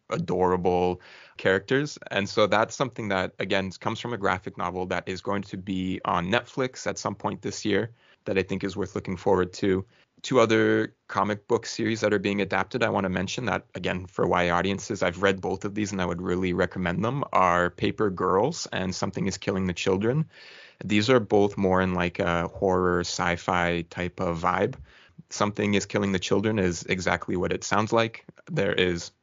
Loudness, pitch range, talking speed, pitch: -26 LUFS, 90-105 Hz, 195 wpm, 95 Hz